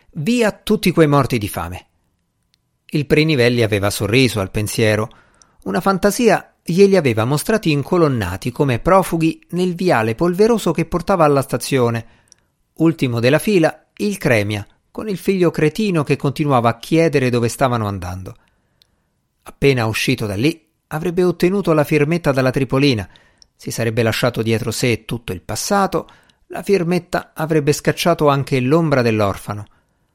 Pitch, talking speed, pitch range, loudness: 140 Hz, 135 wpm, 115-170 Hz, -17 LUFS